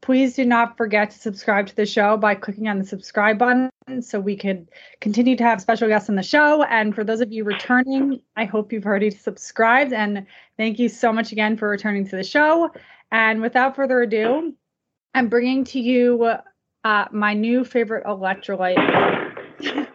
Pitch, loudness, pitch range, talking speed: 225 Hz, -20 LUFS, 210-250 Hz, 185 wpm